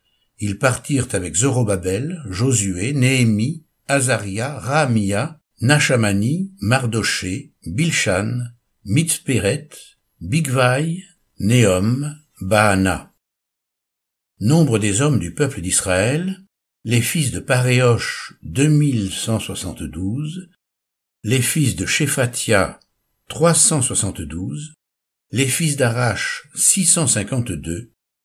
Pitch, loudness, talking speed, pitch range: 120 Hz, -18 LUFS, 85 wpm, 100-145 Hz